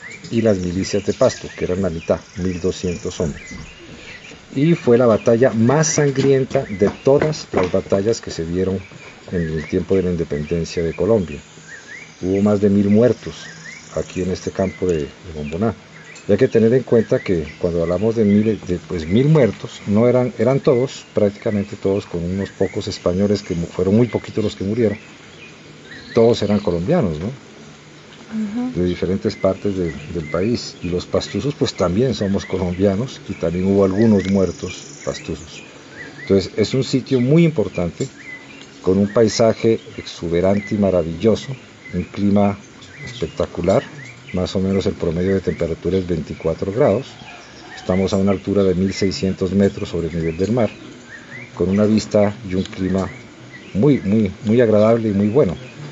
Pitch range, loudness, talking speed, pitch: 90-115 Hz, -19 LUFS, 160 wpm, 100 Hz